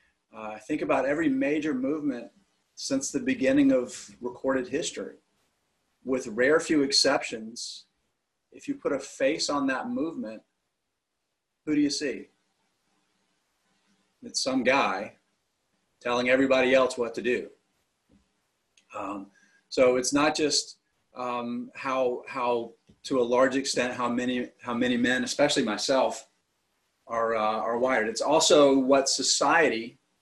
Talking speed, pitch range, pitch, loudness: 130 wpm, 125-150 Hz, 135 Hz, -26 LUFS